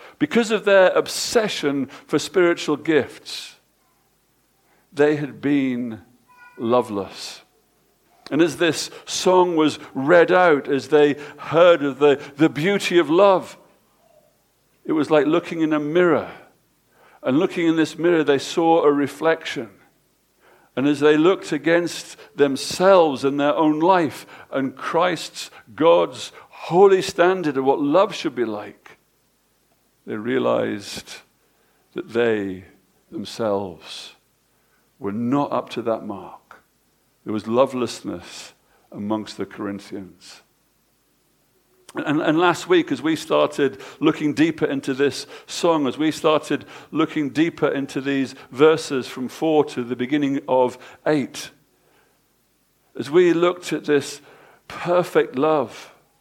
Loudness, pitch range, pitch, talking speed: -20 LUFS, 135-175 Hz, 150 Hz, 125 wpm